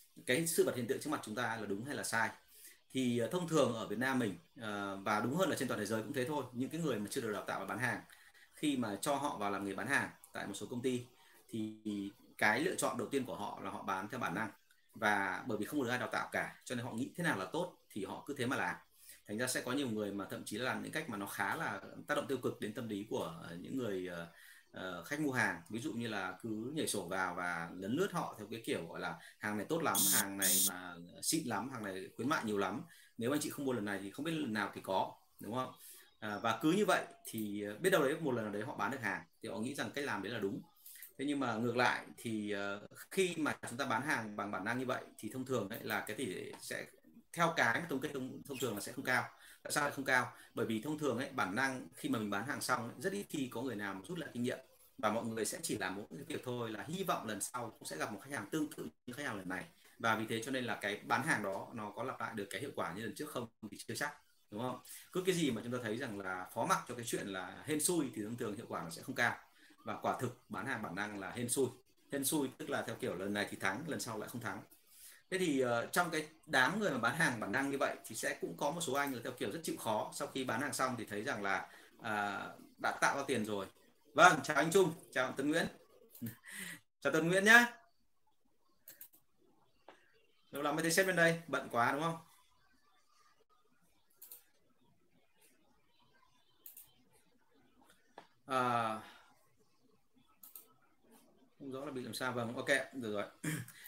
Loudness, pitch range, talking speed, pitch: -37 LUFS, 105-150 Hz, 255 wpm, 125 Hz